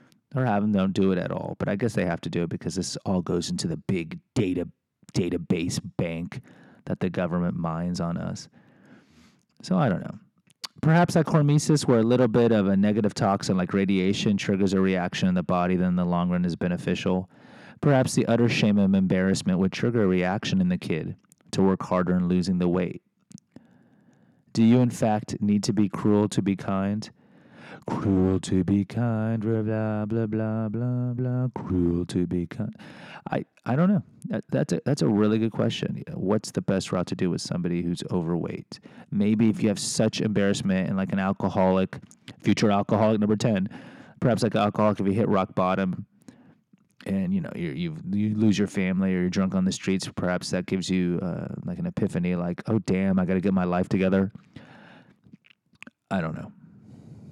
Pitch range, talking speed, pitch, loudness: 95-120 Hz, 195 wpm, 100 Hz, -25 LUFS